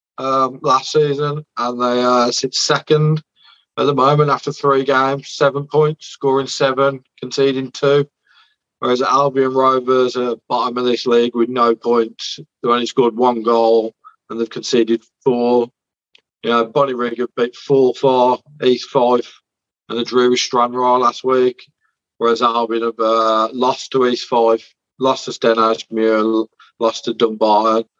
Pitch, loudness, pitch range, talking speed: 125 Hz, -16 LUFS, 115-135 Hz, 150 wpm